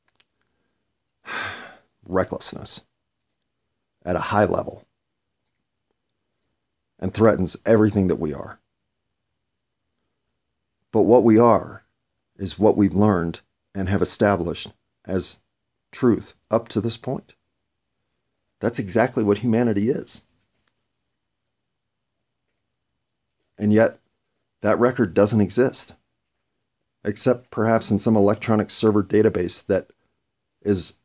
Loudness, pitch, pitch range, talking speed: -20 LUFS, 105 Hz, 95-115 Hz, 95 wpm